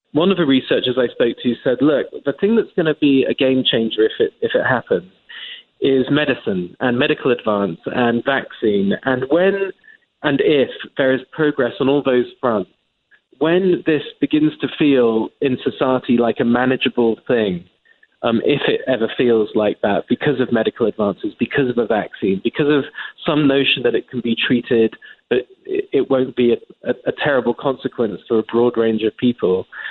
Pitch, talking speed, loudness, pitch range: 135 Hz, 185 wpm, -18 LUFS, 120-170 Hz